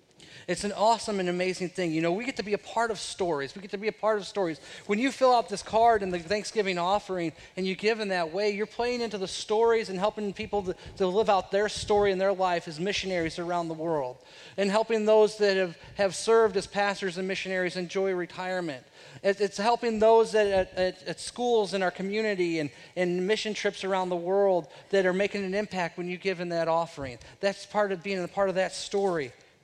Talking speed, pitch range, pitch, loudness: 230 wpm, 180-210 Hz, 195 Hz, -28 LUFS